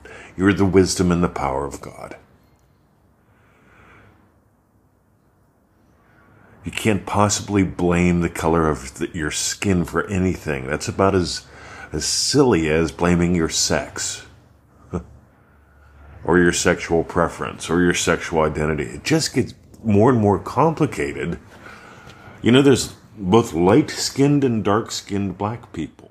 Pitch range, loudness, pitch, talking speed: 85-105 Hz, -19 LUFS, 95 Hz, 120 wpm